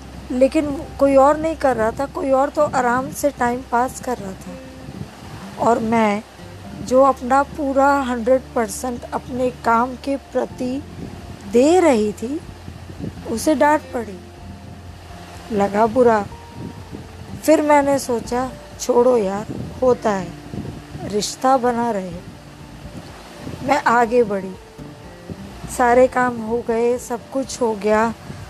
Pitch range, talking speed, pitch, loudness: 215-270 Hz, 120 wpm, 245 Hz, -19 LUFS